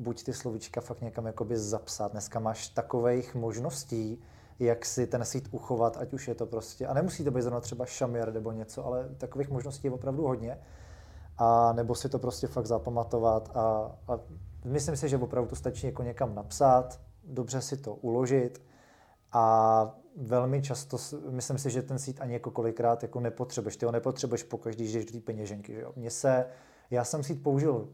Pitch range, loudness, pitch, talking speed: 115-130 Hz, -31 LUFS, 120 Hz, 190 wpm